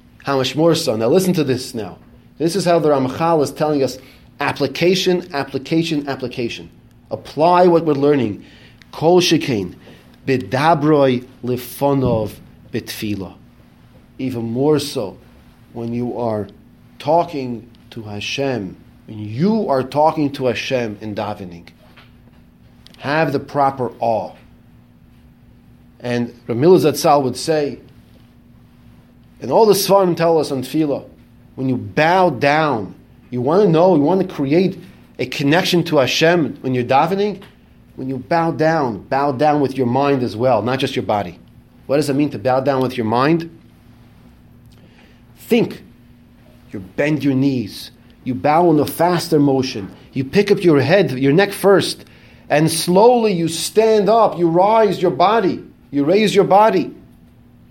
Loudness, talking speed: -17 LUFS, 145 wpm